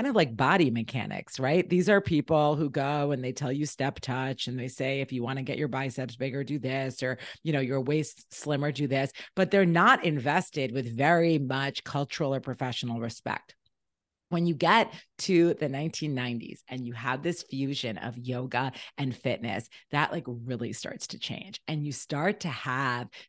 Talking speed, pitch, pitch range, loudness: 190 wpm, 135 Hz, 130-155 Hz, -29 LUFS